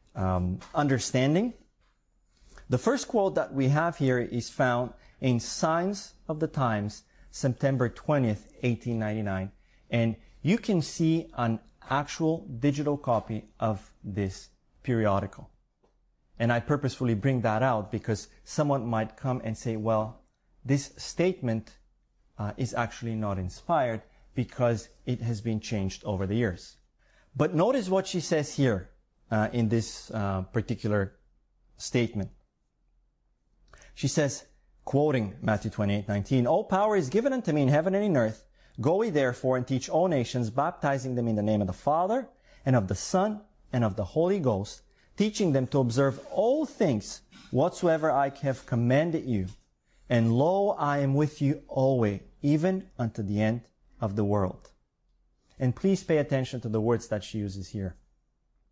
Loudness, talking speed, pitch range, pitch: -28 LUFS, 150 wpm, 110-145 Hz, 125 Hz